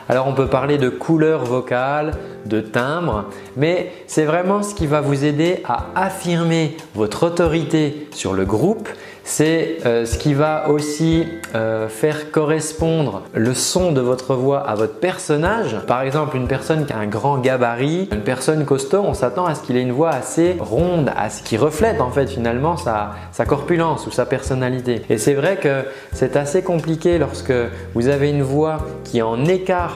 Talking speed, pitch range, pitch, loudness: 180 wpm, 125-165 Hz, 150 Hz, -19 LUFS